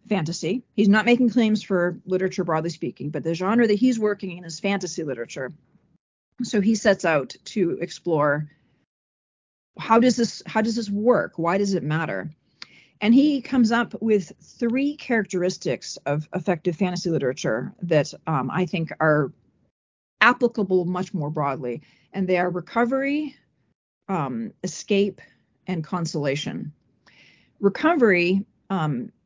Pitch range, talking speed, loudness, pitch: 165-220 Hz, 135 wpm, -23 LUFS, 185 Hz